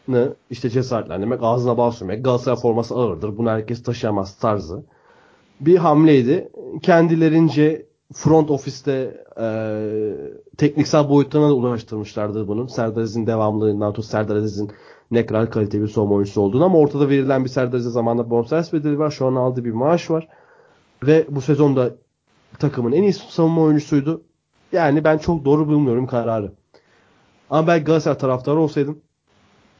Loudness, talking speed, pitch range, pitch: -19 LUFS, 145 wpm, 115-155 Hz, 130 Hz